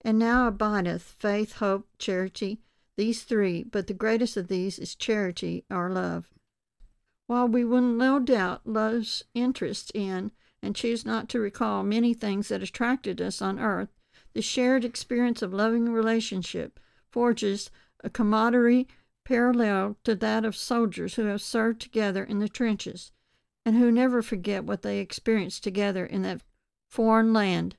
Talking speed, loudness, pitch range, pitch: 150 wpm, -27 LUFS, 200-235 Hz, 220 Hz